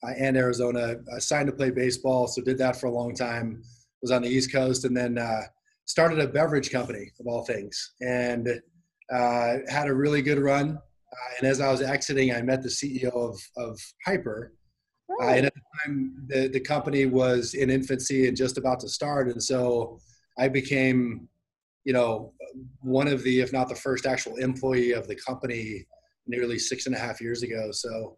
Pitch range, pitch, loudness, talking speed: 120-135 Hz, 130 Hz, -27 LUFS, 190 wpm